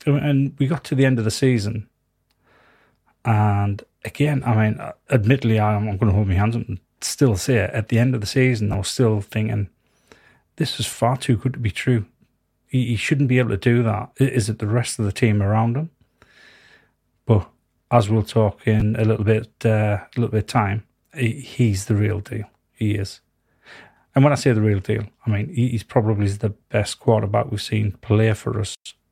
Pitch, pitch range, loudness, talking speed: 110 Hz, 105-125 Hz, -21 LUFS, 200 wpm